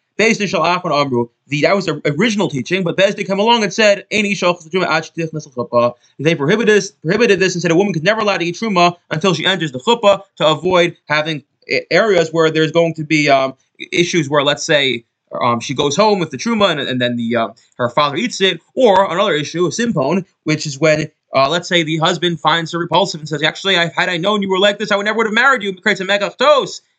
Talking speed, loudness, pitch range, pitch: 220 wpm, -15 LUFS, 155-200 Hz, 175 Hz